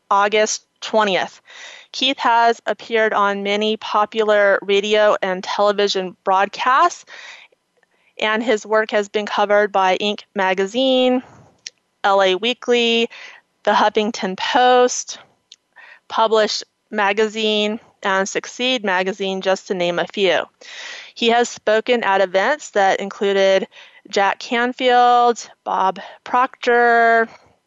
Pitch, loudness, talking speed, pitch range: 215 Hz, -17 LUFS, 100 wpm, 200-245 Hz